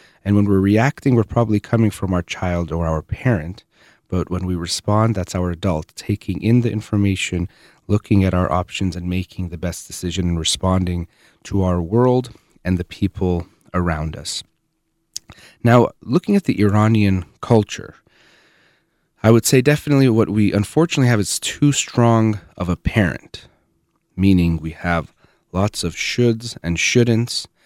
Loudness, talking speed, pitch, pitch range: -19 LUFS, 155 wpm, 100 Hz, 90-115 Hz